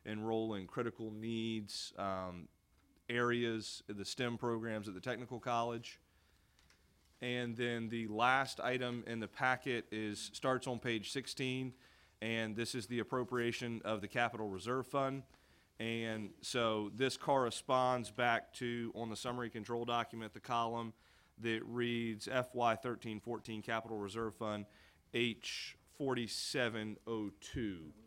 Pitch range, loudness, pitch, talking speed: 110-120 Hz, -39 LUFS, 115 Hz, 135 wpm